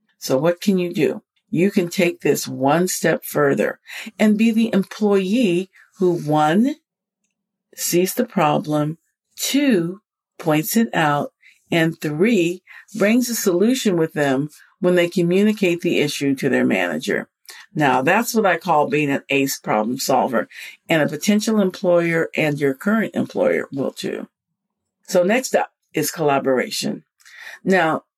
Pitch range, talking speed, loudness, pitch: 160-210 Hz, 140 wpm, -19 LUFS, 180 Hz